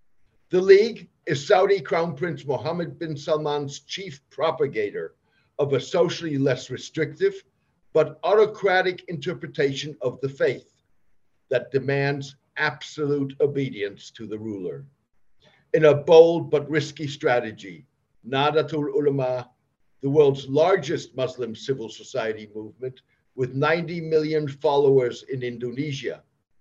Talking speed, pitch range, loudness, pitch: 115 wpm, 130-165 Hz, -23 LUFS, 145 Hz